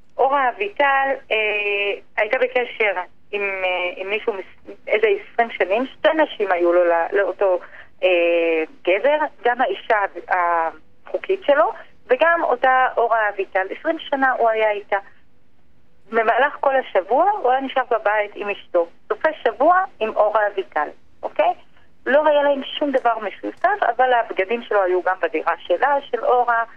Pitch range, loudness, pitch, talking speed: 190-275 Hz, -20 LUFS, 230 Hz, 140 wpm